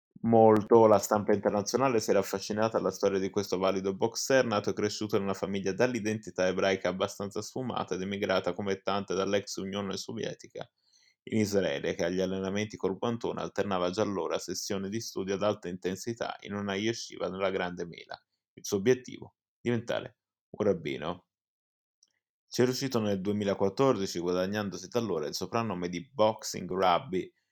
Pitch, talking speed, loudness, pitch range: 100 Hz, 155 wpm, -30 LUFS, 95-110 Hz